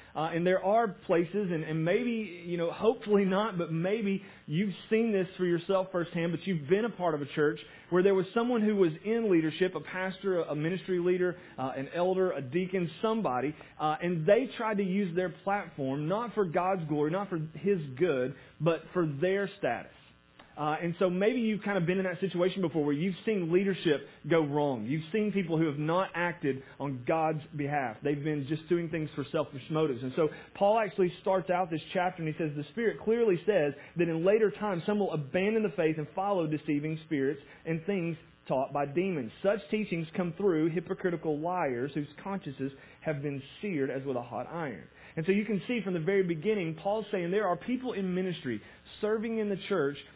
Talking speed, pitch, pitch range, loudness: 205 wpm, 175 Hz, 155-195 Hz, -31 LUFS